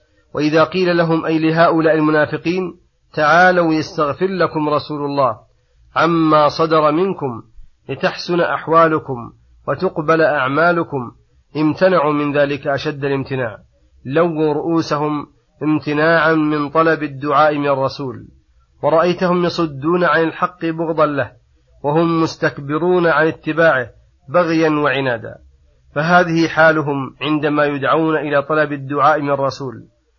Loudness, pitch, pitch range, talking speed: -16 LUFS, 155 Hz, 140-165 Hz, 105 wpm